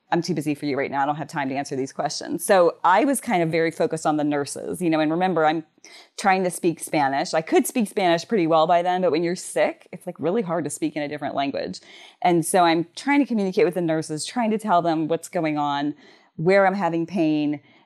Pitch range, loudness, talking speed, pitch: 155-185 Hz, -22 LUFS, 255 wpm, 165 Hz